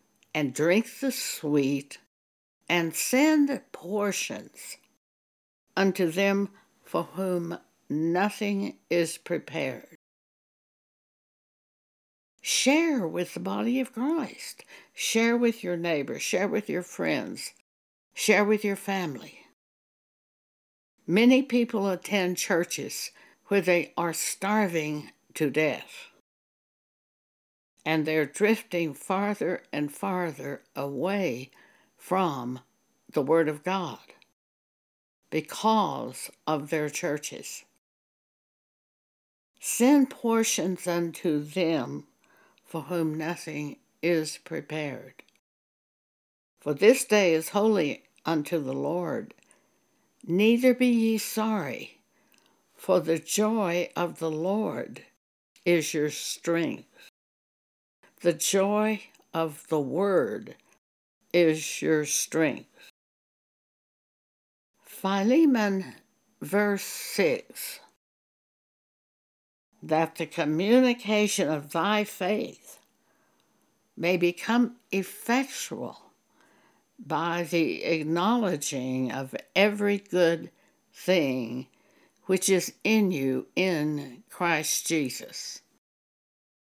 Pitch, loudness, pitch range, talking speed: 175 Hz, -27 LUFS, 155-210 Hz, 85 wpm